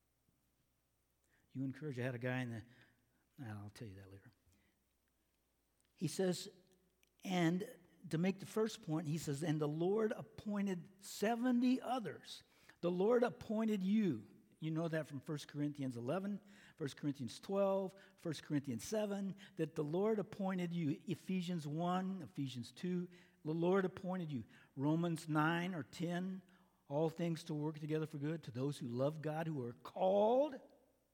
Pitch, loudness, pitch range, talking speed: 165 Hz, -40 LUFS, 140-190 Hz, 150 wpm